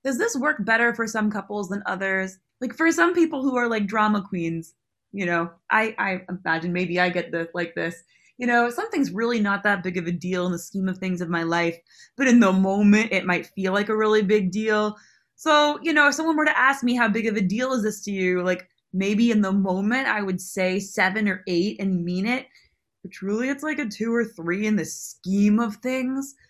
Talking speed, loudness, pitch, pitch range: 235 wpm, -23 LUFS, 205 Hz, 185-235 Hz